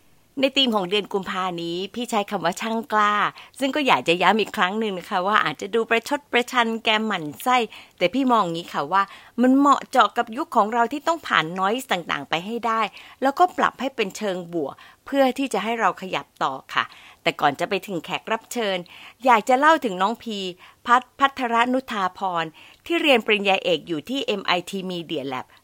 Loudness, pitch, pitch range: -22 LUFS, 220 Hz, 185-250 Hz